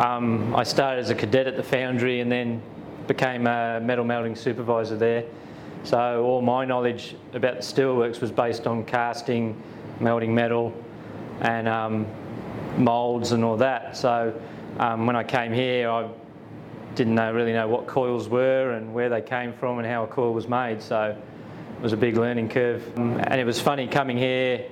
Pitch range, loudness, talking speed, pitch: 115-125 Hz, -24 LUFS, 180 wpm, 120 Hz